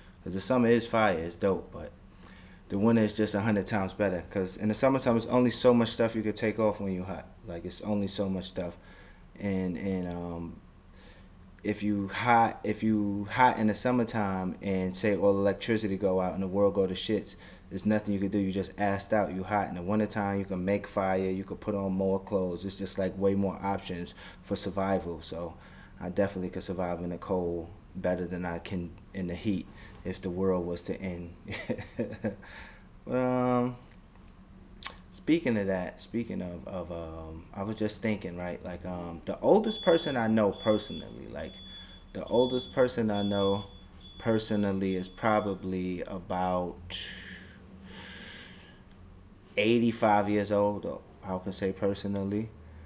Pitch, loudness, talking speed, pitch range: 95 Hz, -30 LUFS, 175 wpm, 90-105 Hz